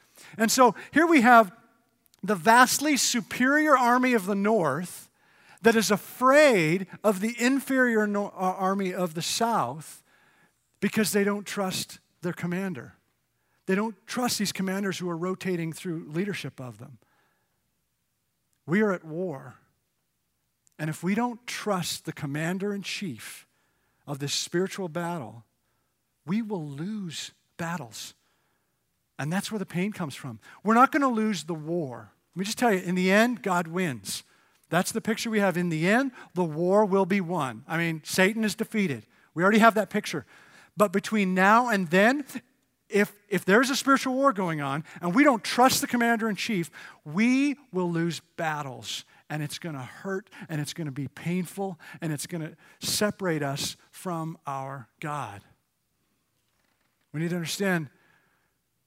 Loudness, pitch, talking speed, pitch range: -26 LUFS, 185 Hz, 160 wpm, 160-220 Hz